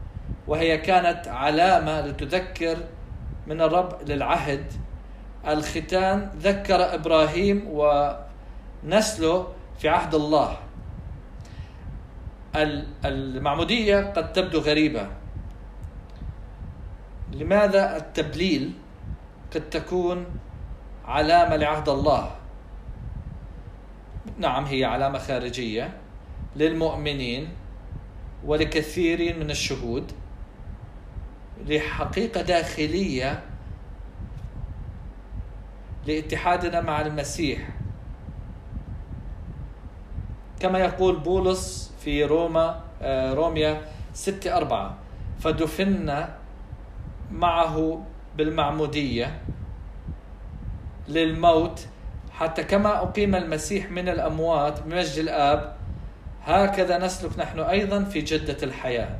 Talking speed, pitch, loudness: 65 wpm, 150 Hz, -24 LUFS